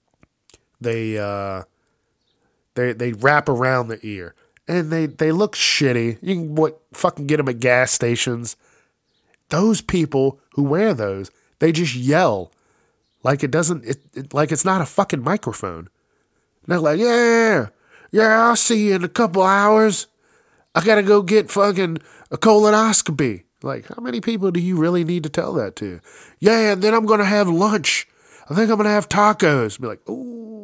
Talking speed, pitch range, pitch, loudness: 170 wpm, 135-210 Hz, 165 Hz, -18 LUFS